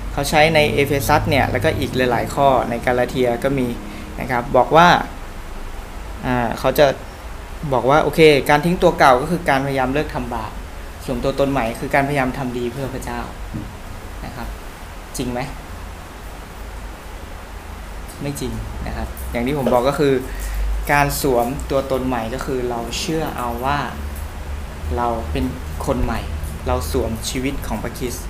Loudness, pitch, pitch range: -19 LUFS, 120 Hz, 80-135 Hz